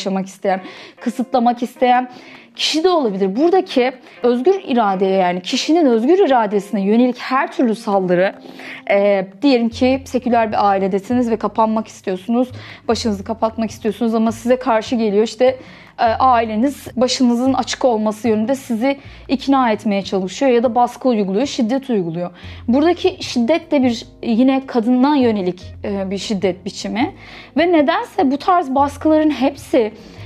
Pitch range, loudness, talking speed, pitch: 210-270 Hz, -17 LUFS, 135 wpm, 240 Hz